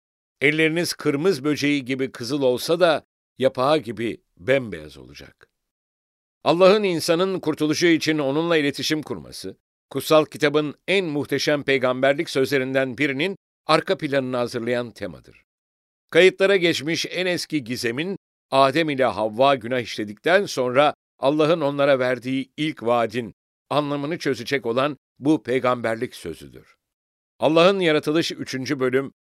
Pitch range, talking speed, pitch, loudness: 125-155 Hz, 110 wpm, 140 Hz, -21 LUFS